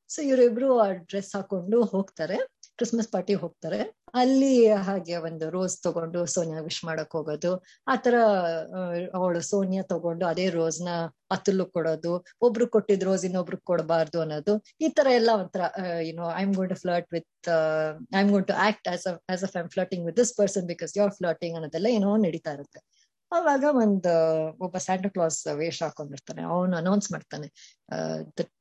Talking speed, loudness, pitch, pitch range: 135 wpm, -26 LUFS, 185 Hz, 165-205 Hz